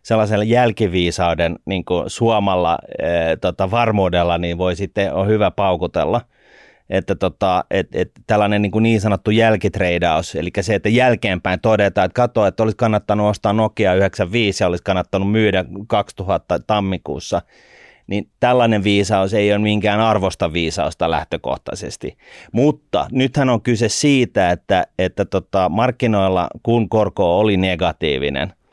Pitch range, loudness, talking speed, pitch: 95-110 Hz, -17 LUFS, 135 wpm, 105 Hz